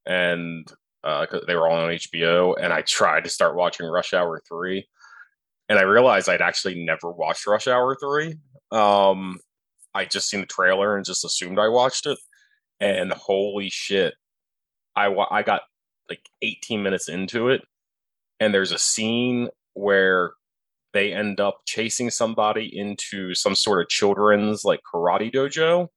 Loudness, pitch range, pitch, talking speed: -22 LUFS, 95-125 Hz, 105 Hz, 155 wpm